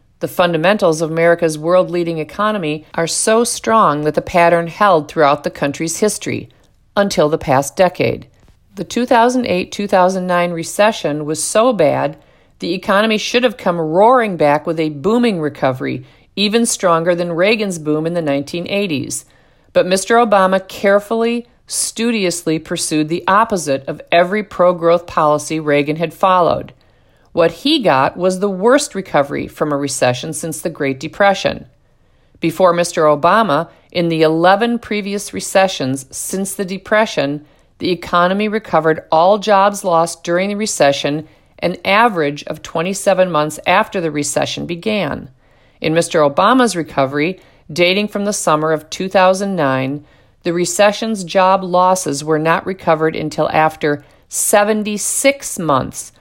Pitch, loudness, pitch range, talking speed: 175 Hz, -15 LUFS, 155-200 Hz, 135 wpm